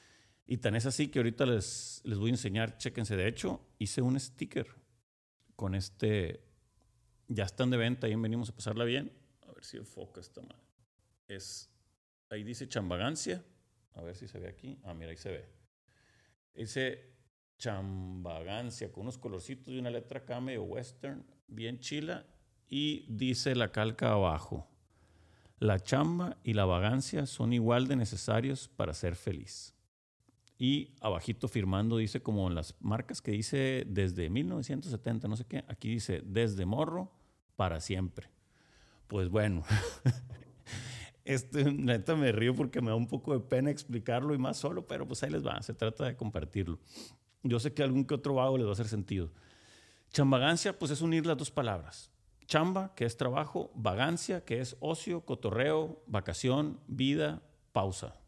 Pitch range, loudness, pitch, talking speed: 105-130 Hz, -34 LUFS, 115 Hz, 160 wpm